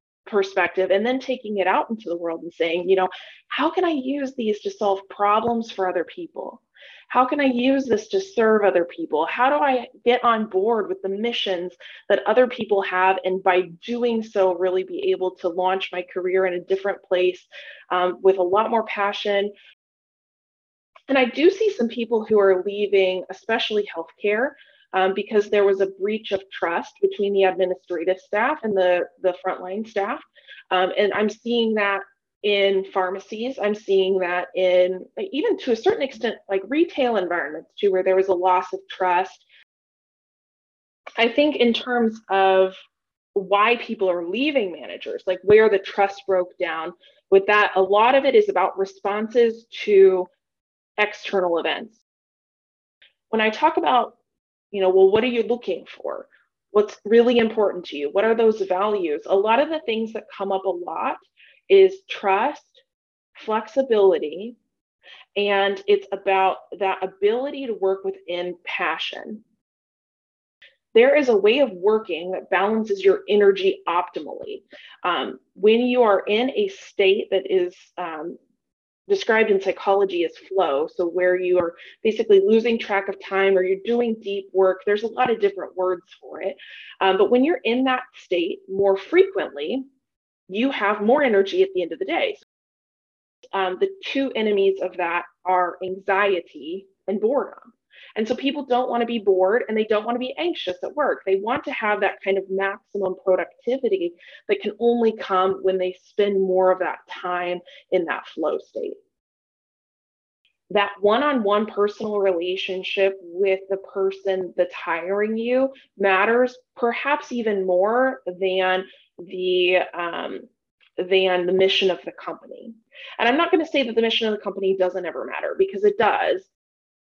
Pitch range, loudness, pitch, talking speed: 185-240 Hz, -21 LUFS, 200 Hz, 165 wpm